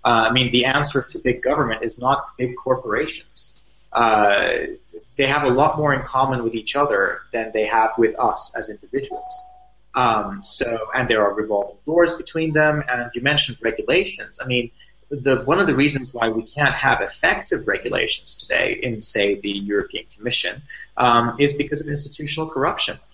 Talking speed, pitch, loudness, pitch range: 175 wpm, 130 Hz, -19 LUFS, 115-150 Hz